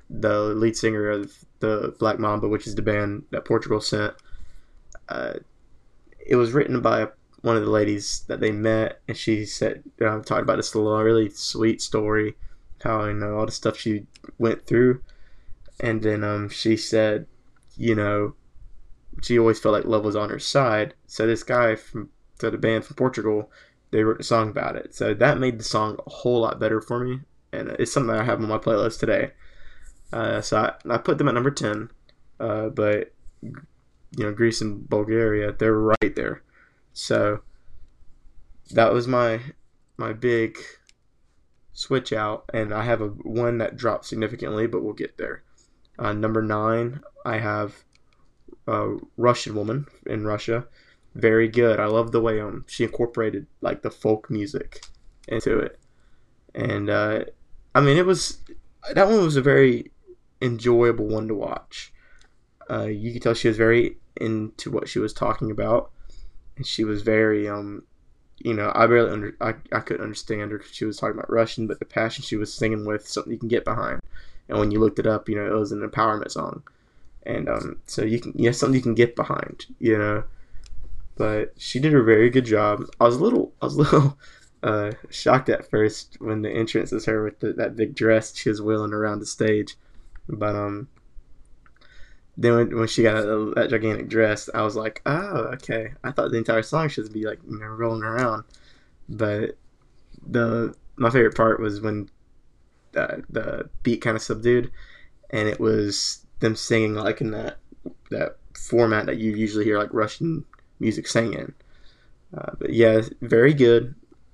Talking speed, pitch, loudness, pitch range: 180 wpm, 110 Hz, -23 LUFS, 105-120 Hz